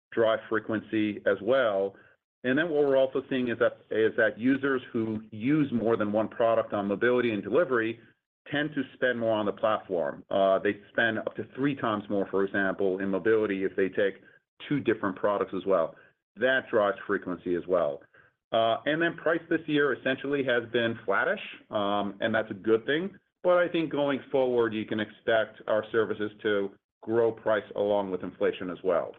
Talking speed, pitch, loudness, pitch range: 185 wpm, 115 Hz, -28 LUFS, 105-135 Hz